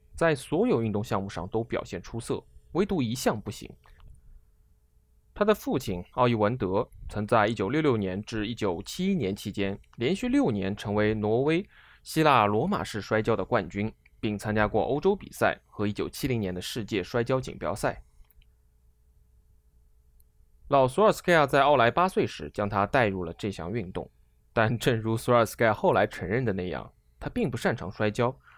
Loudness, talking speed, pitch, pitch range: -27 LUFS, 235 characters per minute, 105 Hz, 90-120 Hz